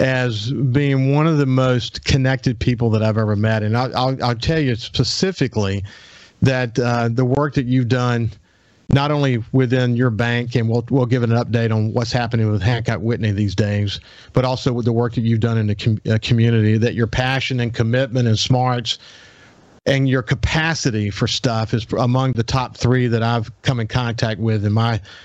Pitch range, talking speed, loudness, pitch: 115-130 Hz, 195 wpm, -19 LUFS, 120 Hz